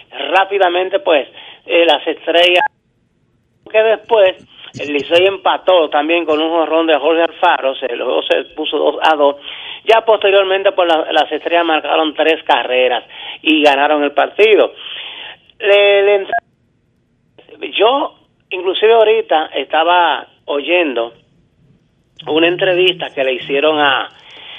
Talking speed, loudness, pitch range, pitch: 125 wpm, -13 LUFS, 150-195 Hz, 165 Hz